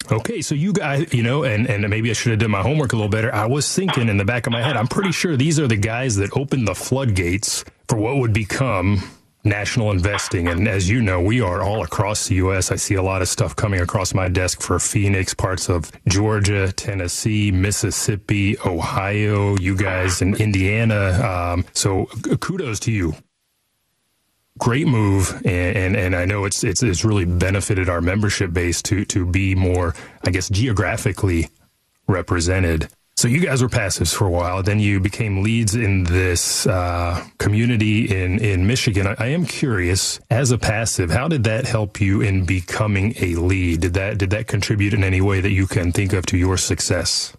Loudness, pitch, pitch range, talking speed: -19 LUFS, 105 Hz, 95-115 Hz, 195 wpm